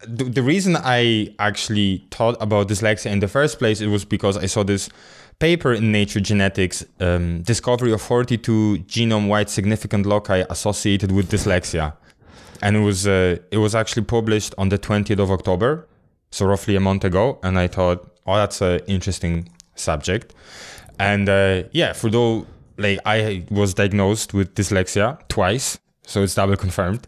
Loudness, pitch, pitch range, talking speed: -20 LUFS, 105 Hz, 95-110 Hz, 160 wpm